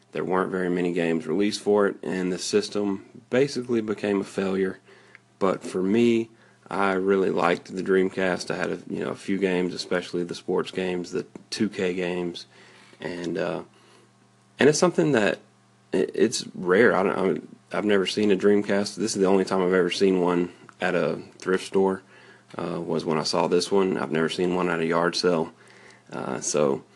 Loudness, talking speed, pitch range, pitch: -25 LUFS, 185 wpm, 90-100 Hz, 95 Hz